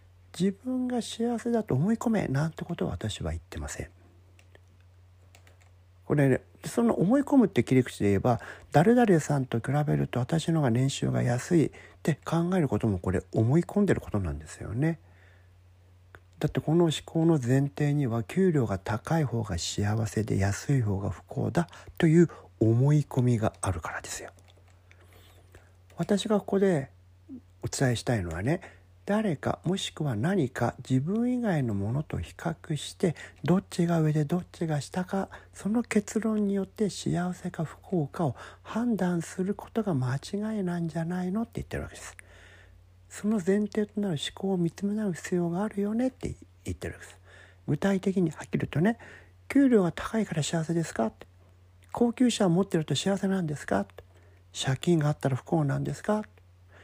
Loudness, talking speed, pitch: -28 LUFS, 290 characters per minute, 140 Hz